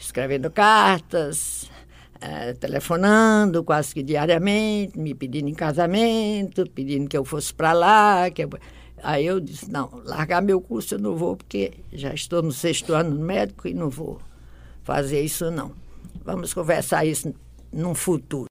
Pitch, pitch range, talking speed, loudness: 155 Hz, 140-180 Hz, 155 wpm, -22 LUFS